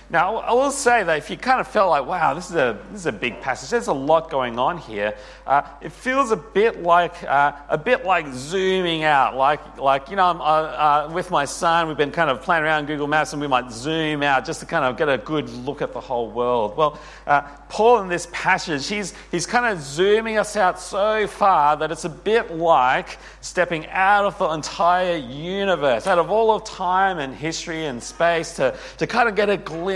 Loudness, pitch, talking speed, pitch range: -20 LUFS, 165 Hz, 230 wpm, 145-195 Hz